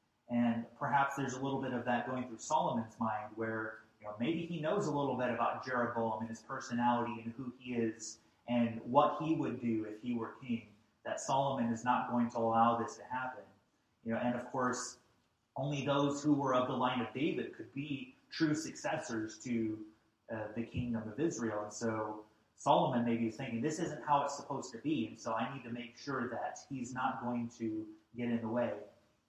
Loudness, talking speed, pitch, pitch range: -36 LUFS, 210 wpm, 120 Hz, 115-135 Hz